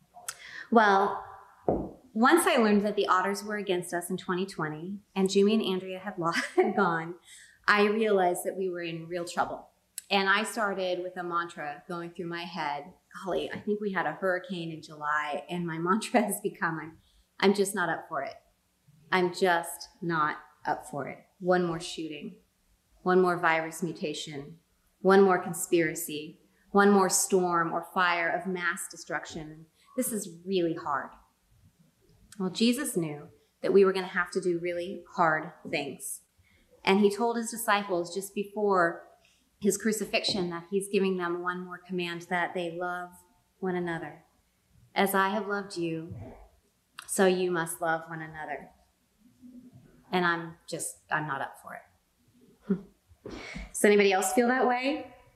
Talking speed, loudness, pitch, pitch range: 160 wpm, -29 LUFS, 180 Hz, 170-200 Hz